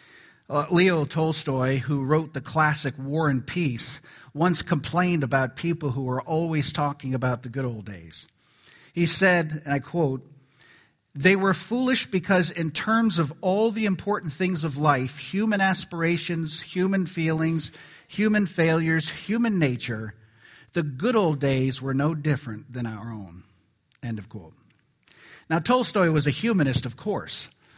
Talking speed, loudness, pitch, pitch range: 150 wpm, -25 LUFS, 155 Hz, 135-180 Hz